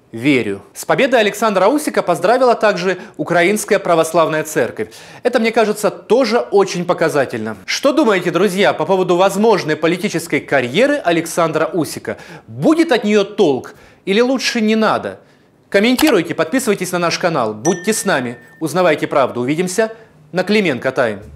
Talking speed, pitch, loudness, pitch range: 135 wpm, 185 Hz, -15 LUFS, 160-220 Hz